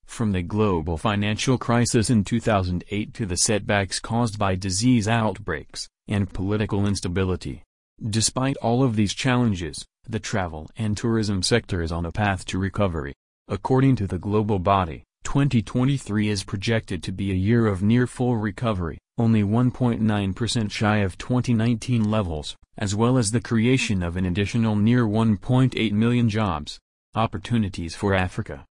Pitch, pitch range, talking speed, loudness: 105 Hz, 95-115 Hz, 145 wpm, -23 LUFS